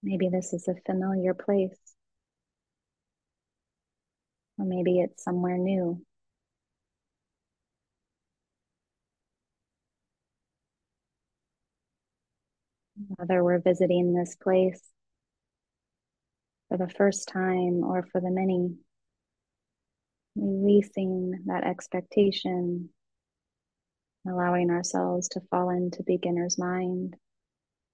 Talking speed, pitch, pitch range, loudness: 75 wpm, 180 Hz, 180-190 Hz, -28 LUFS